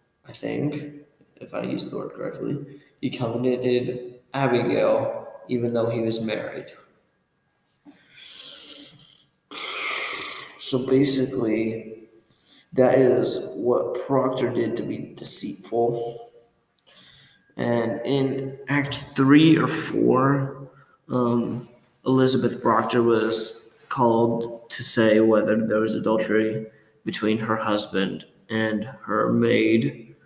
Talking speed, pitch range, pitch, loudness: 95 wpm, 110-135 Hz, 120 Hz, -21 LUFS